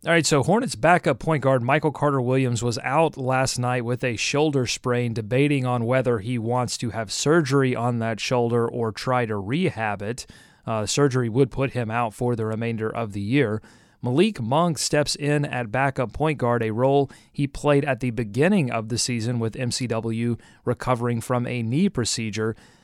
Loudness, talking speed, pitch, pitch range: -23 LUFS, 185 wpm, 125 Hz, 115-140 Hz